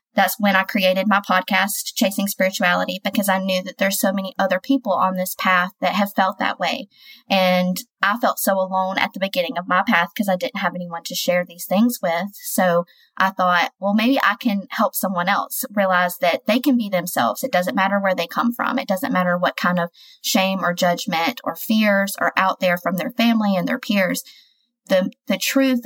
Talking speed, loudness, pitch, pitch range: 215 wpm, -20 LUFS, 195 Hz, 180-220 Hz